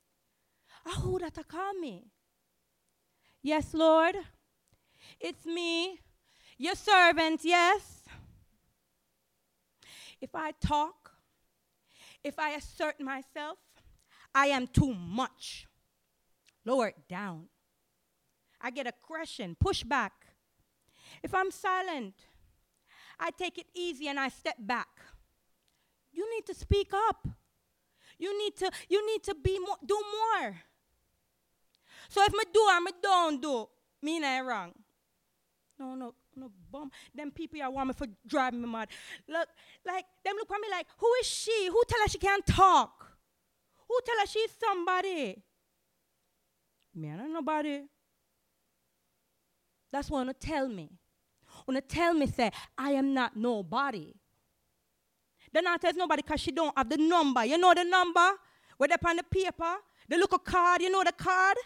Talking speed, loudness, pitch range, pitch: 140 wpm, -30 LUFS, 260-370 Hz, 320 Hz